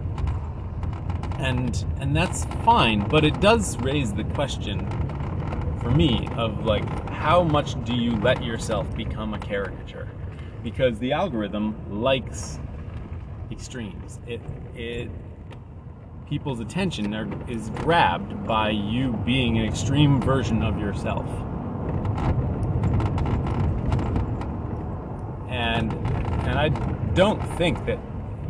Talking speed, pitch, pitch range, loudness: 105 wpm, 110 Hz, 100-120 Hz, -25 LUFS